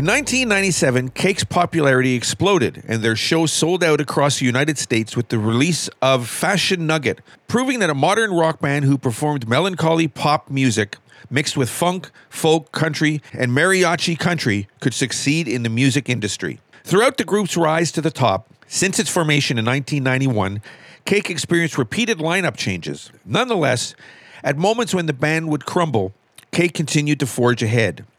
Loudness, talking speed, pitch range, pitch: -19 LUFS, 160 wpm, 125-170 Hz, 150 Hz